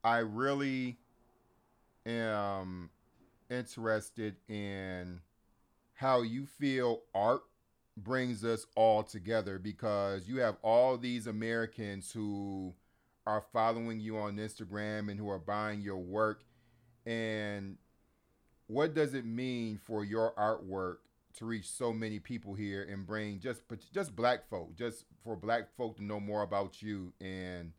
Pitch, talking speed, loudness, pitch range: 110 Hz, 130 wpm, -36 LUFS, 100-120 Hz